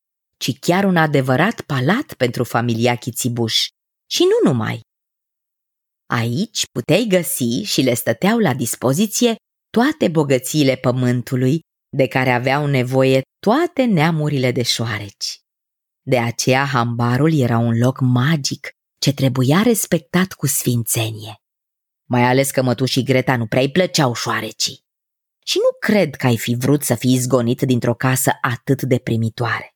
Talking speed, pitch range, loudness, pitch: 135 wpm, 125-160 Hz, -18 LUFS, 130 Hz